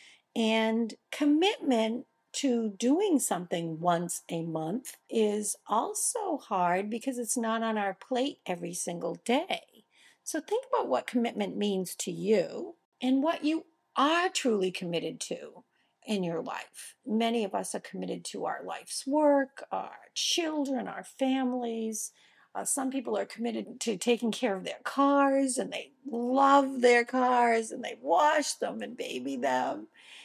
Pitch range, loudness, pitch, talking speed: 215-285 Hz, -30 LUFS, 245 Hz, 145 wpm